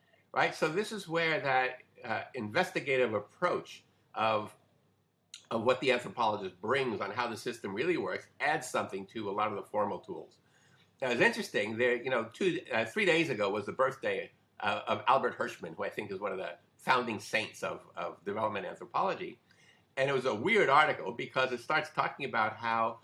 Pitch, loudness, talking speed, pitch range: 130 Hz, -32 LUFS, 190 wpm, 115-170 Hz